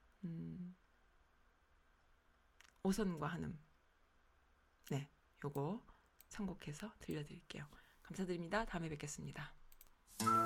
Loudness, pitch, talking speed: -45 LUFS, 140 Hz, 185 characters per minute